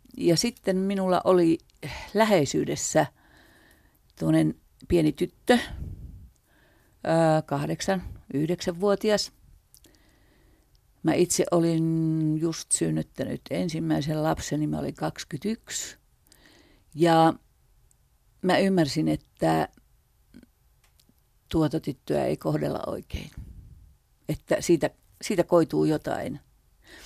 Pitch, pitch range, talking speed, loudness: 165 Hz, 150-185 Hz, 75 wpm, -26 LUFS